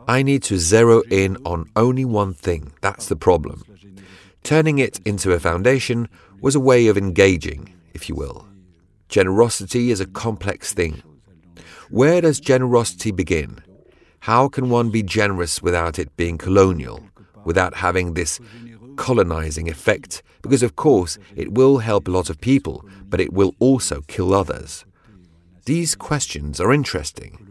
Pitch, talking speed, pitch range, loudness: 100 Hz, 150 wpm, 90-120 Hz, -19 LUFS